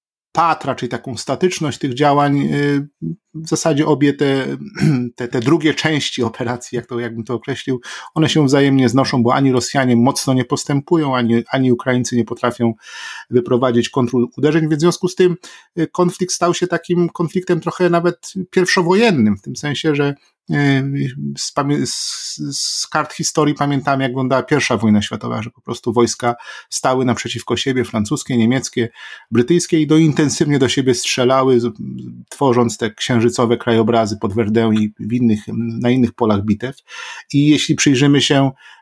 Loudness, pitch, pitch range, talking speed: -16 LUFS, 135 Hz, 120-155 Hz, 150 wpm